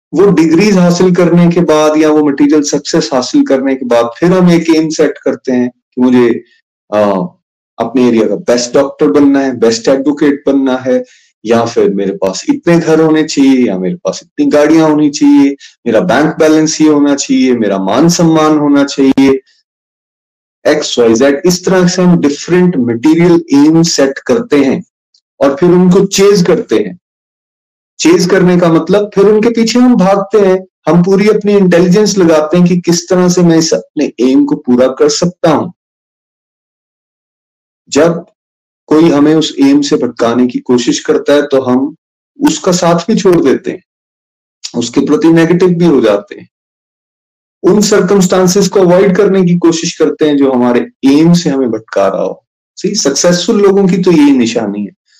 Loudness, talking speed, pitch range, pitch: -9 LUFS, 175 wpm, 135-180 Hz, 155 Hz